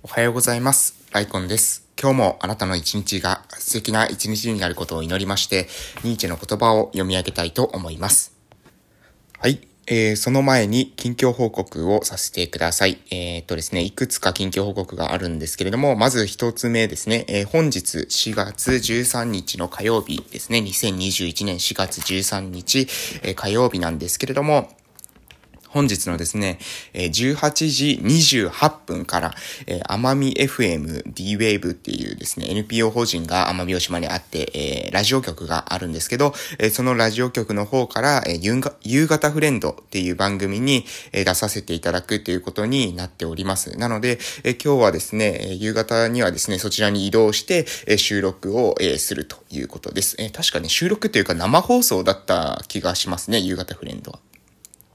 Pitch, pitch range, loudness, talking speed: 105 Hz, 90-125 Hz, -20 LUFS, 330 characters per minute